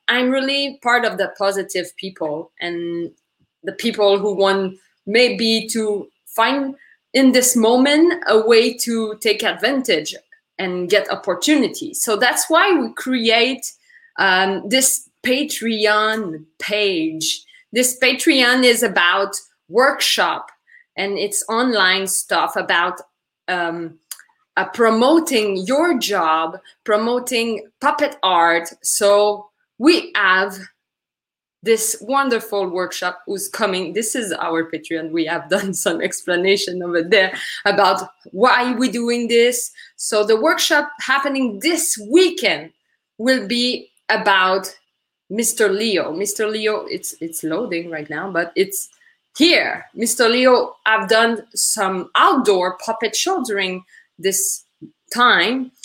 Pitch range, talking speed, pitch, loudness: 190-255 Hz, 115 wpm, 220 Hz, -17 LUFS